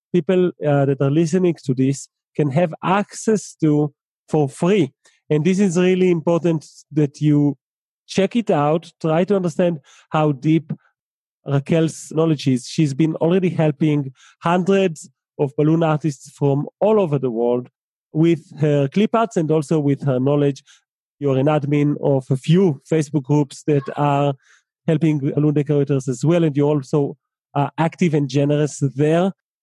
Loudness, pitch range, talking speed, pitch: -19 LUFS, 145-170 Hz, 160 wpm, 155 Hz